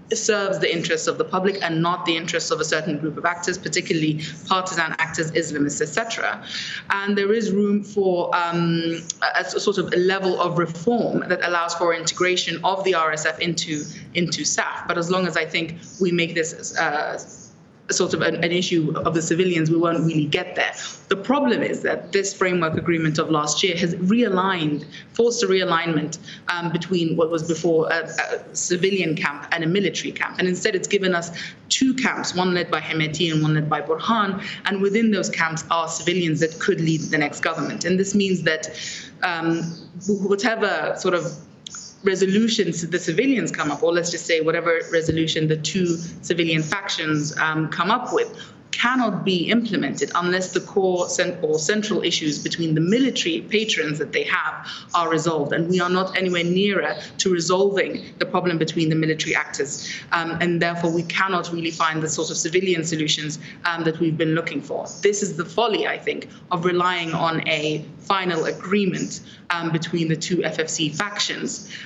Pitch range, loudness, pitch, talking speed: 165-190 Hz, -22 LUFS, 175 Hz, 185 wpm